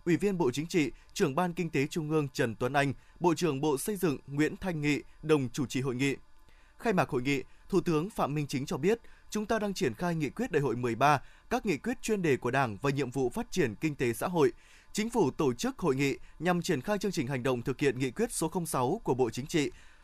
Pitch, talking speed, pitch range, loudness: 155 Hz, 260 wpm, 140-190 Hz, -31 LUFS